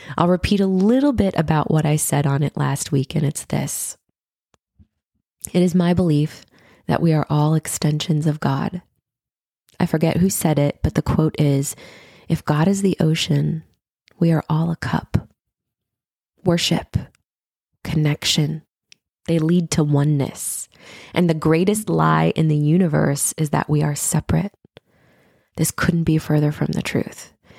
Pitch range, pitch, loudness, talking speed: 145-170 Hz, 155 Hz, -20 LUFS, 155 wpm